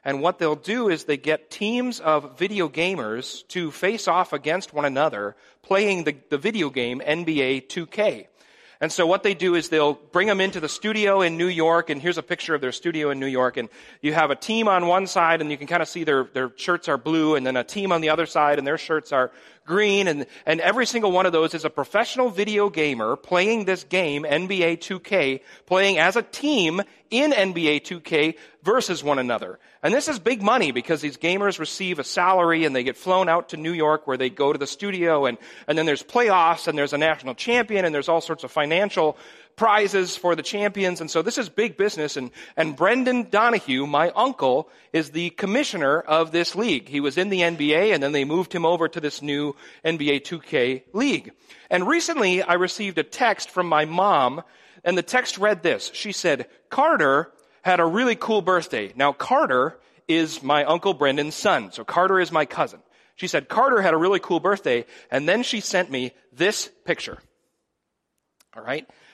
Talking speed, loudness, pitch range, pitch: 205 wpm, -22 LUFS, 150-195 Hz, 170 Hz